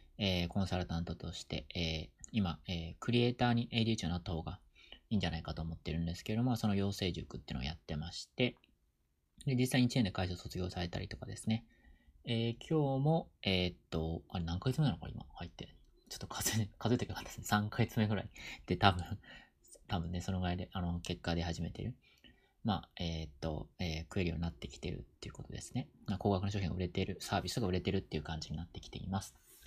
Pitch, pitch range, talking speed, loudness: 90 Hz, 85-110 Hz, 445 characters per minute, -37 LUFS